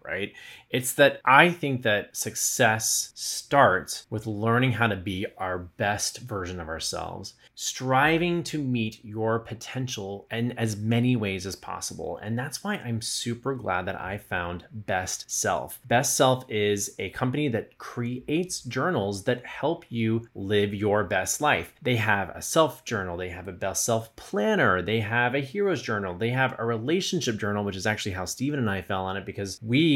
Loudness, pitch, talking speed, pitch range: -26 LUFS, 115 Hz, 175 wpm, 100-130 Hz